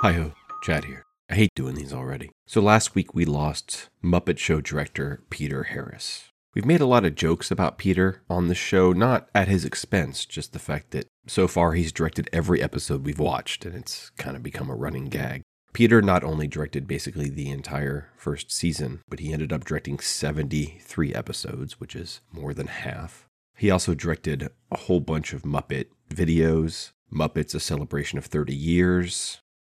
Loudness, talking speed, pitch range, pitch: -25 LUFS, 180 wpm, 75-90 Hz, 80 Hz